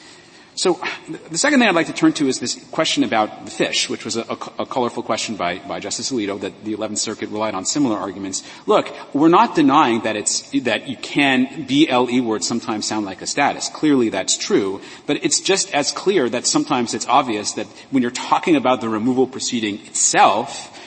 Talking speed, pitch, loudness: 205 wpm, 125 Hz, -19 LUFS